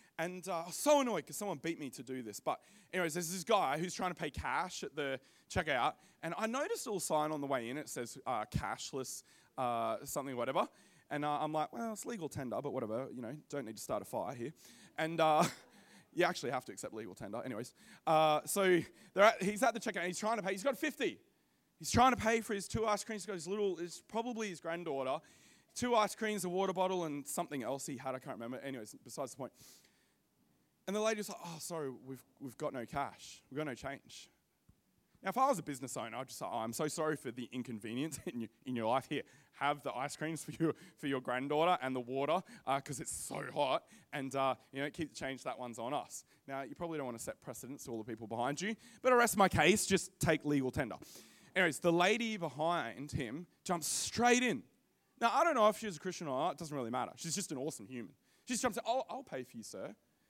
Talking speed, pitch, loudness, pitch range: 250 wpm, 160 Hz, -37 LUFS, 135-195 Hz